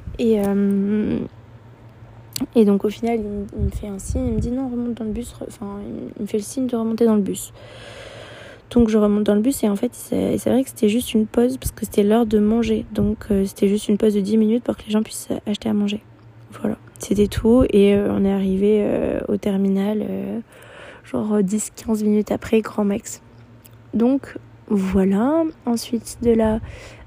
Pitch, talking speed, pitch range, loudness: 210 Hz, 195 wpm, 200-230 Hz, -20 LUFS